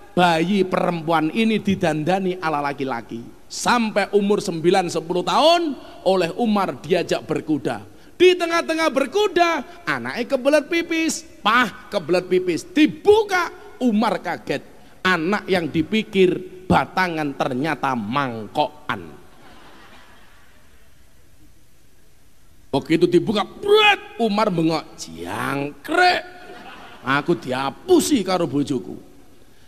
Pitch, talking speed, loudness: 185 Hz, 85 wpm, -20 LUFS